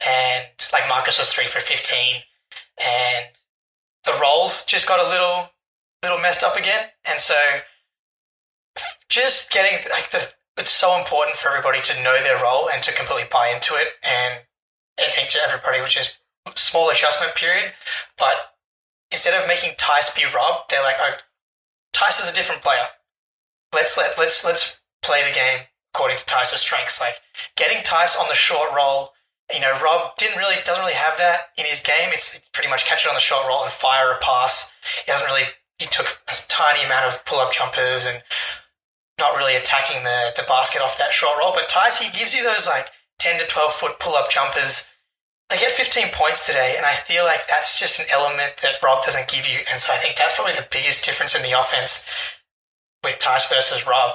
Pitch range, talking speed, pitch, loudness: 125-180 Hz, 195 wpm, 150 Hz, -19 LUFS